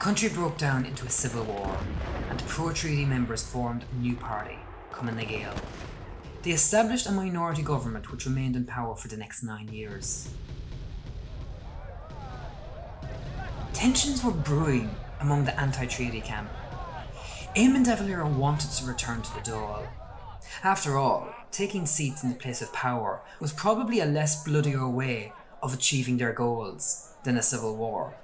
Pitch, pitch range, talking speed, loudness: 130 Hz, 115-155 Hz, 155 wpm, -28 LUFS